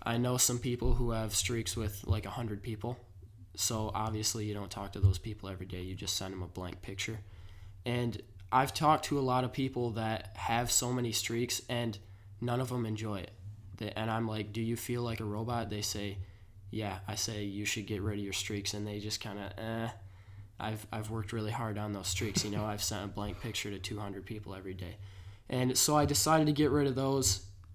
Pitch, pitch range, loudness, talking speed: 105 Hz, 100-115 Hz, -34 LUFS, 225 wpm